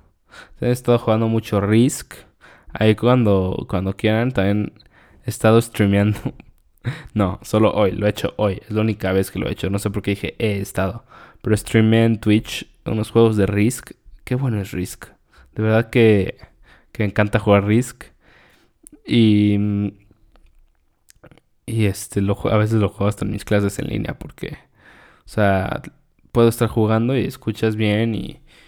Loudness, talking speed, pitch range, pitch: -19 LUFS, 165 wpm, 100-115 Hz, 105 Hz